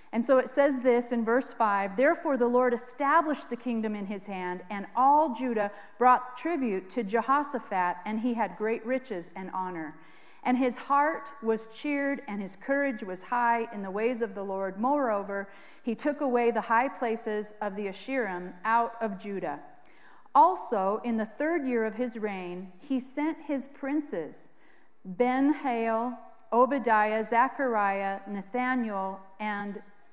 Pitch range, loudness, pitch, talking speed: 205-255 Hz, -29 LUFS, 230 Hz, 155 wpm